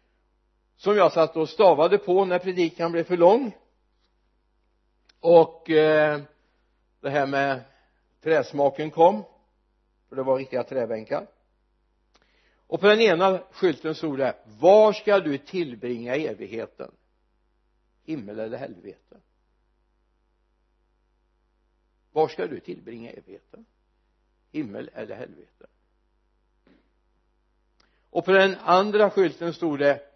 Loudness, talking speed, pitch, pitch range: -22 LUFS, 105 wpm, 145 Hz, 110-170 Hz